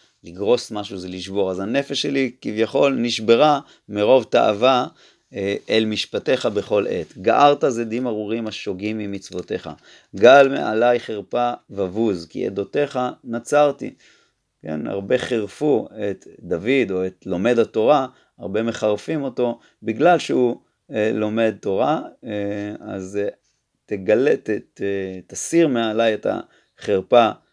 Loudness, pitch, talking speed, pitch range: -20 LUFS, 110 Hz, 120 wpm, 100-125 Hz